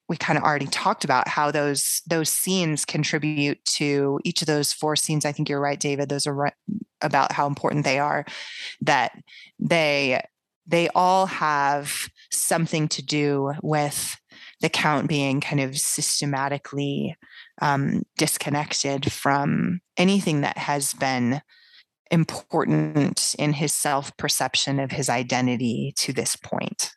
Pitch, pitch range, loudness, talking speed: 145 Hz, 140-155 Hz, -23 LUFS, 140 wpm